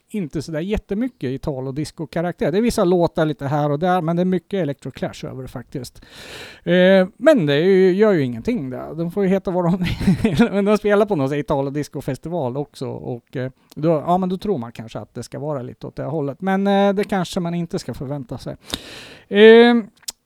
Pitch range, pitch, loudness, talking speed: 140-195 Hz, 170 Hz, -19 LUFS, 210 wpm